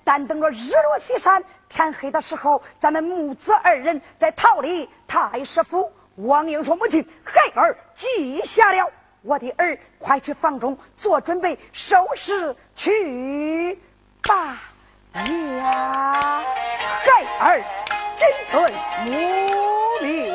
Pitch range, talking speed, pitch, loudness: 285-370 Hz, 160 characters per minute, 320 Hz, -20 LUFS